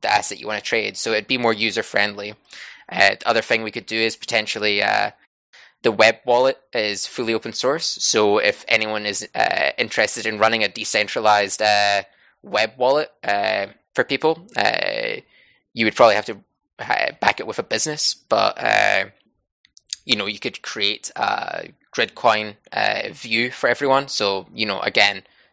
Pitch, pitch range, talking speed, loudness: 115 Hz, 105-135 Hz, 170 wpm, -20 LUFS